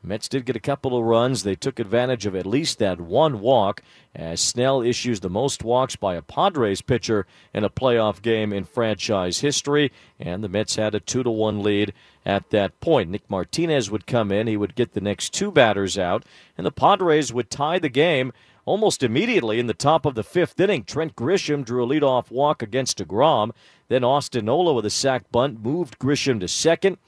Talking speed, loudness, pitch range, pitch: 205 wpm, -22 LUFS, 105-140 Hz, 120 Hz